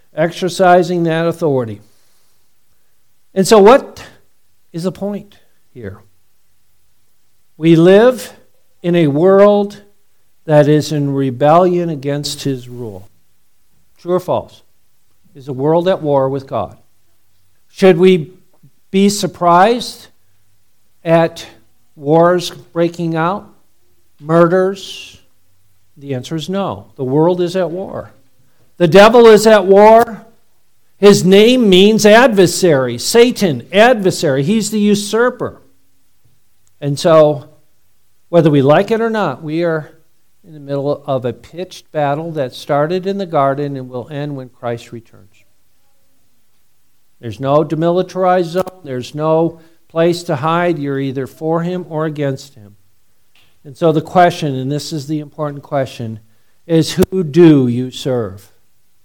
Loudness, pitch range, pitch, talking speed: -13 LUFS, 120-180 Hz, 150 Hz, 125 wpm